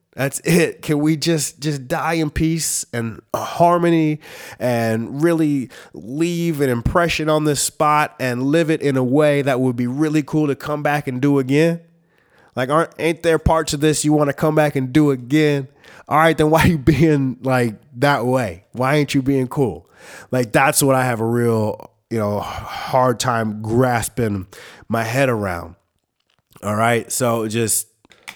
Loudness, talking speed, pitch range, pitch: -18 LUFS, 180 wpm, 120-155 Hz, 140 Hz